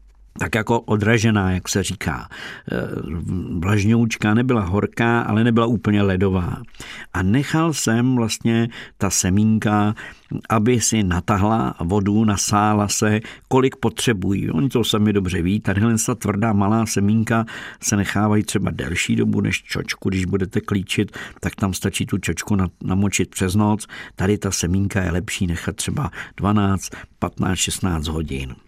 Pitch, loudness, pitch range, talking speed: 105 Hz, -20 LUFS, 95-110 Hz, 140 wpm